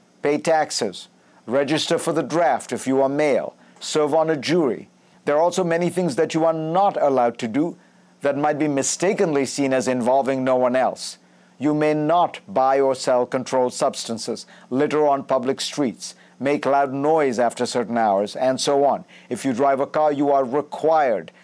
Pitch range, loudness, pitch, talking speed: 130-155 Hz, -21 LUFS, 140 Hz, 180 wpm